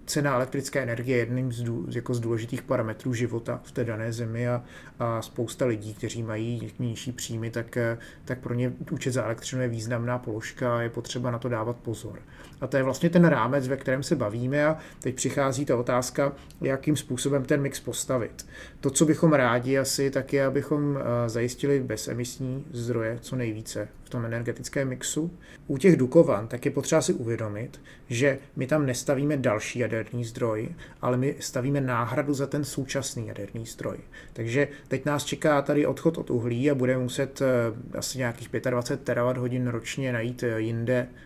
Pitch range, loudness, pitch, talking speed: 120-140 Hz, -27 LUFS, 125 Hz, 175 wpm